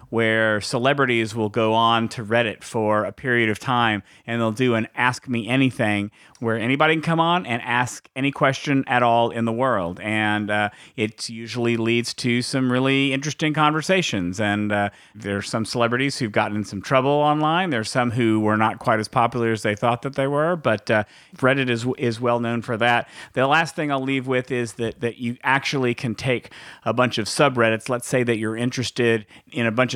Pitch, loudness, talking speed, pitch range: 120 Hz, -21 LUFS, 205 wpm, 110-130 Hz